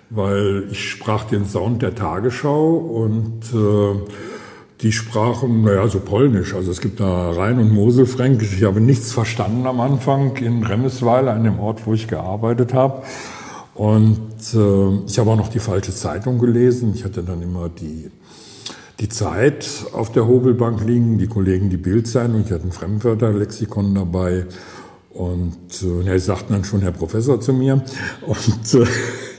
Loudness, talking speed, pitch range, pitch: -18 LUFS, 165 wpm, 100-120 Hz, 110 Hz